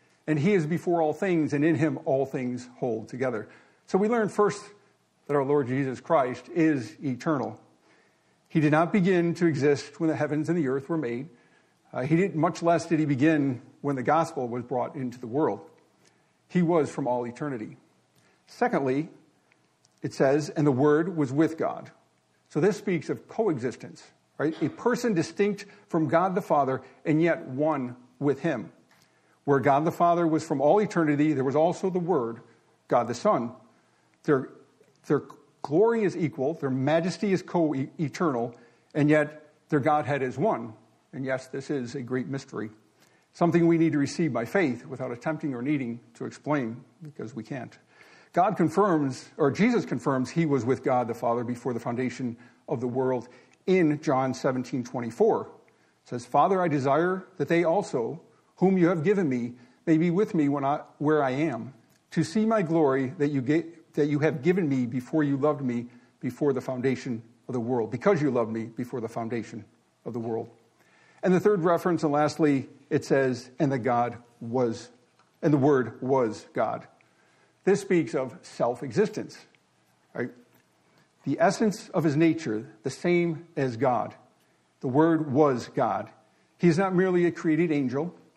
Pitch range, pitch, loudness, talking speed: 125-165 Hz, 150 Hz, -26 LUFS, 175 wpm